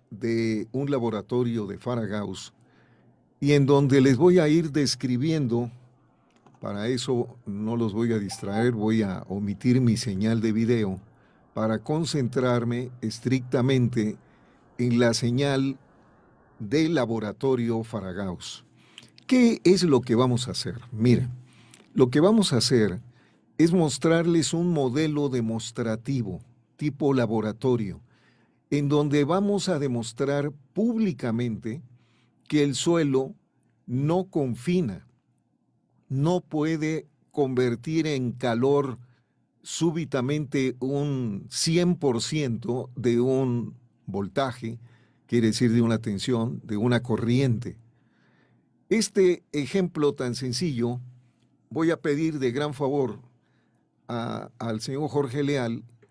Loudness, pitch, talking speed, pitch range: -25 LUFS, 125 Hz, 110 wpm, 115-145 Hz